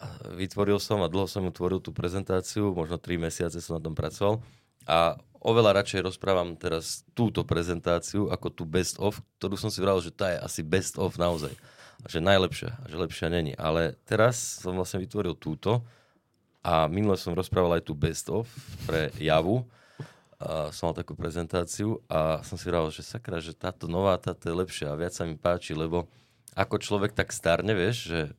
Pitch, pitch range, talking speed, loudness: 90 Hz, 85-105 Hz, 190 wpm, -29 LUFS